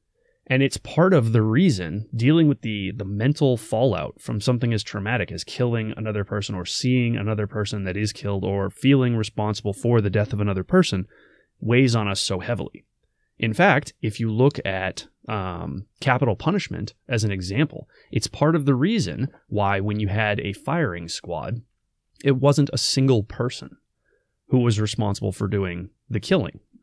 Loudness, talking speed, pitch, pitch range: -23 LUFS, 170 wpm, 110 Hz, 100-130 Hz